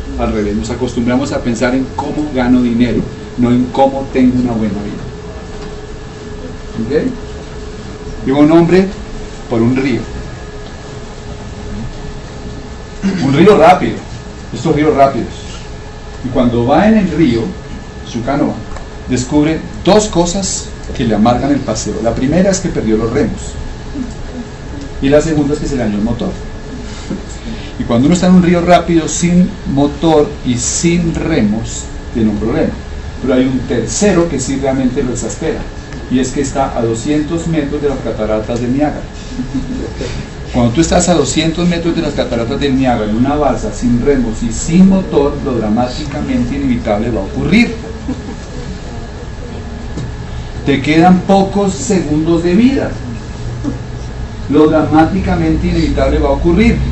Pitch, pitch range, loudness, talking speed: 135 Hz, 115-155 Hz, -13 LUFS, 145 wpm